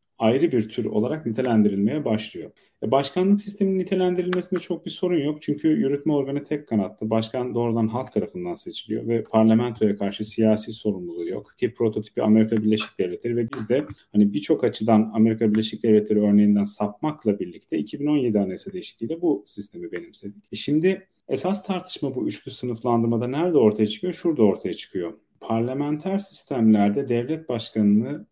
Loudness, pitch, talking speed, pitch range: -23 LUFS, 115 Hz, 150 wpm, 105-150 Hz